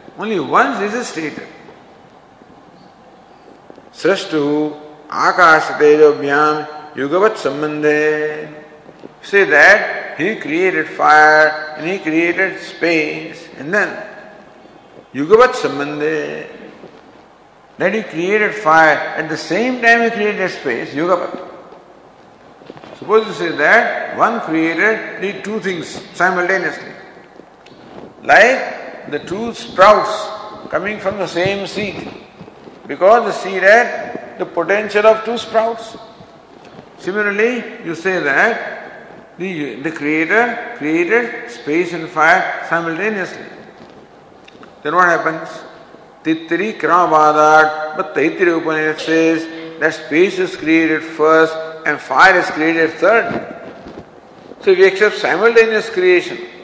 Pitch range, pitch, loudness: 155-215 Hz, 180 Hz, -14 LUFS